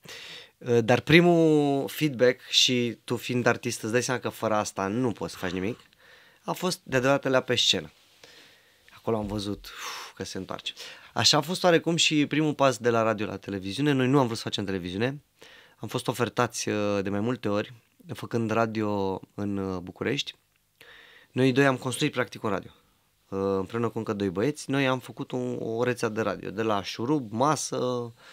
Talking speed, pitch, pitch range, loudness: 175 wpm, 120 Hz, 105-130 Hz, -26 LUFS